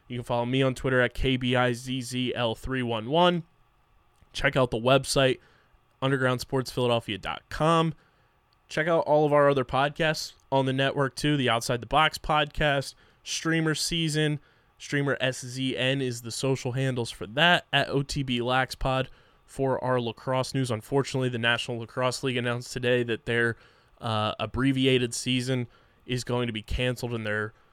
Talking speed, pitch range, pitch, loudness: 145 wpm, 120-140 Hz, 130 Hz, -26 LUFS